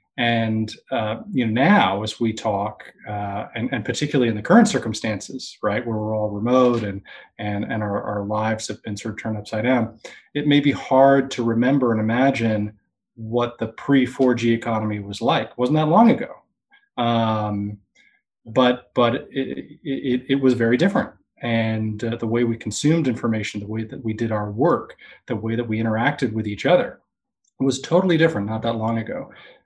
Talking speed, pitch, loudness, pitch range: 185 wpm, 115 Hz, -21 LUFS, 110-135 Hz